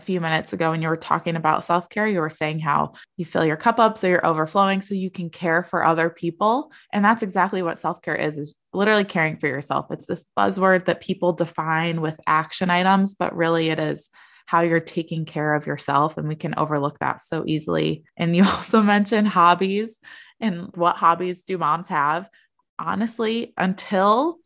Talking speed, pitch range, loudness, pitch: 190 wpm, 160-195 Hz, -22 LUFS, 175 Hz